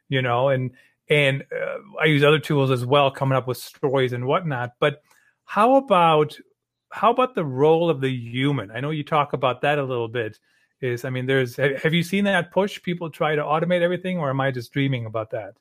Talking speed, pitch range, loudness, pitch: 220 wpm, 130-165 Hz, -22 LUFS, 145 Hz